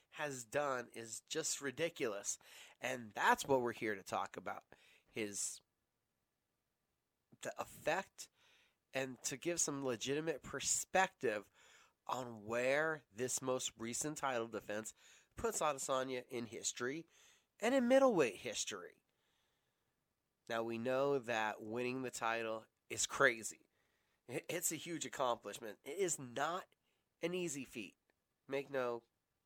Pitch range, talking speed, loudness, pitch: 115-155 Hz, 120 wpm, -40 LUFS, 130 Hz